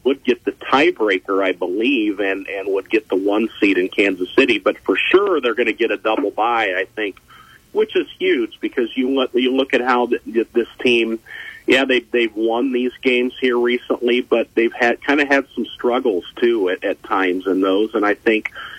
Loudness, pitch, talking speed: -18 LUFS, 135 Hz, 205 wpm